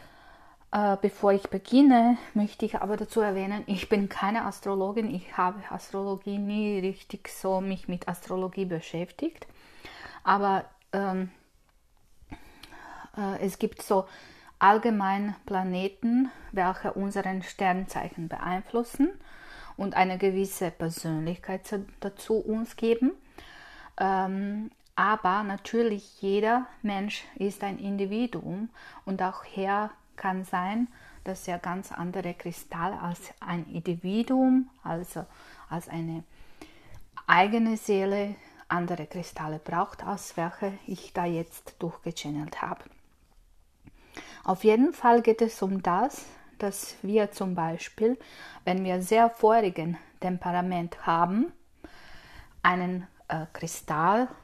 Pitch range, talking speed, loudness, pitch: 180-220 Hz, 110 wpm, -28 LUFS, 195 Hz